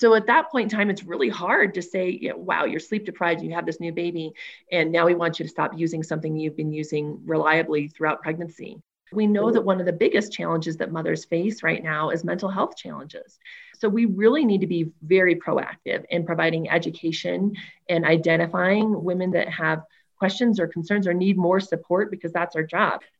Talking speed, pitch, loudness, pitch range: 210 wpm, 170 Hz, -23 LUFS, 165-200 Hz